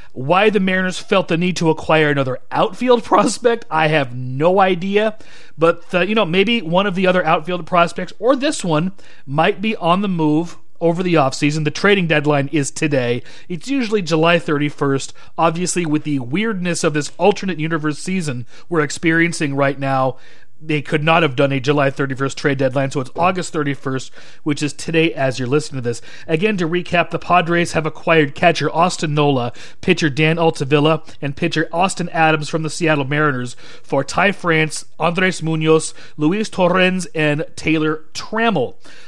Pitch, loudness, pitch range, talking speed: 160 Hz, -17 LUFS, 150-180 Hz, 170 wpm